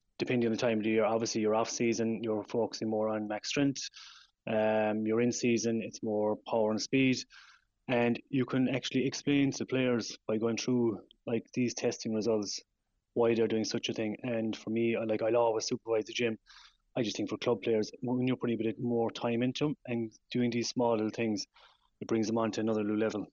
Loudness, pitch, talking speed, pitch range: -32 LUFS, 115 Hz, 210 wpm, 110-120 Hz